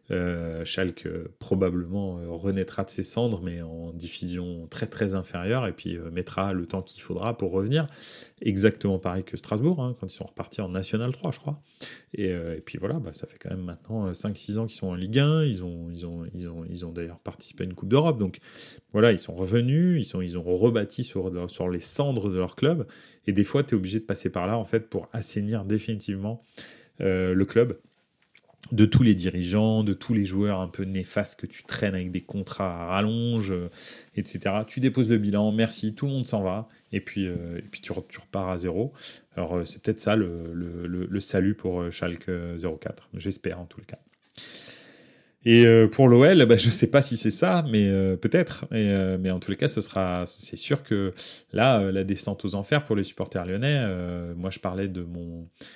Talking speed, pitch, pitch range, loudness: 225 wpm, 100 Hz, 90-115 Hz, -26 LUFS